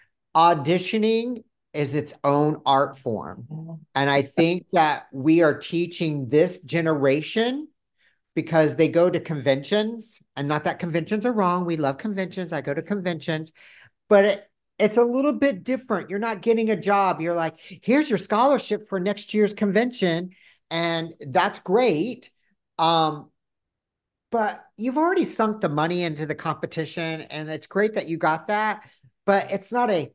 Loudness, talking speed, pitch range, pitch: -23 LUFS, 155 wpm, 155-210 Hz, 175 Hz